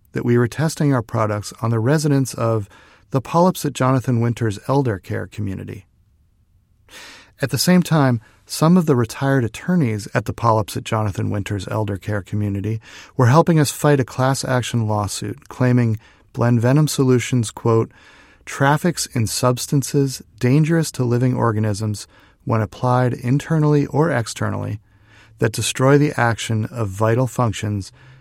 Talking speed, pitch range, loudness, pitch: 145 wpm, 110-135 Hz, -19 LUFS, 120 Hz